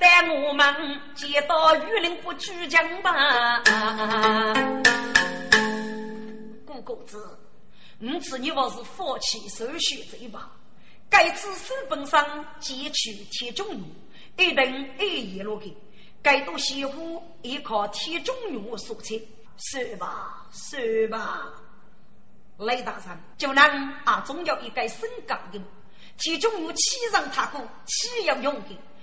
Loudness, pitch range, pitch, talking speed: -24 LUFS, 220-330 Hz, 275 Hz, 180 characters per minute